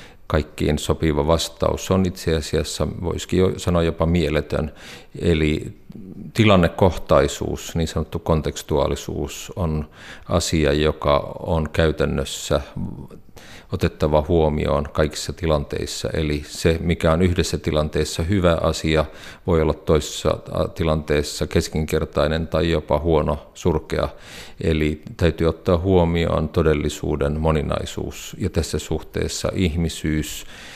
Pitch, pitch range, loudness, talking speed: 80 Hz, 75-85 Hz, -21 LUFS, 100 wpm